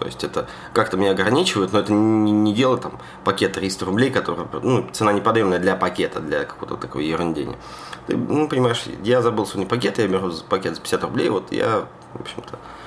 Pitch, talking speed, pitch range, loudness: 105 Hz, 200 wpm, 95-120 Hz, -21 LUFS